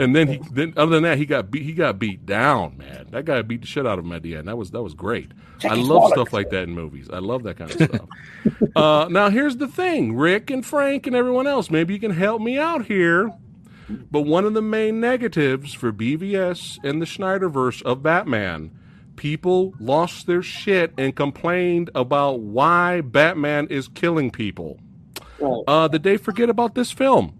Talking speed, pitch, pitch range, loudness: 205 wpm, 155 Hz, 125-195 Hz, -20 LUFS